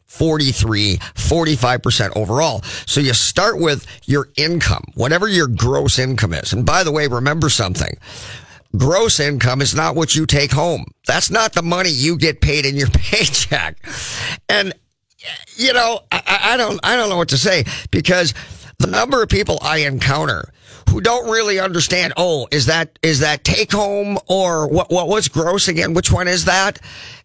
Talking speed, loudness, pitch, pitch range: 170 wpm, -16 LUFS, 155 Hz, 130-180 Hz